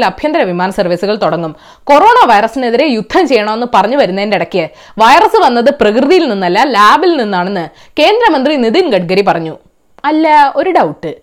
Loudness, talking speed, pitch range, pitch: -9 LUFS, 130 wpm, 190-300 Hz, 240 Hz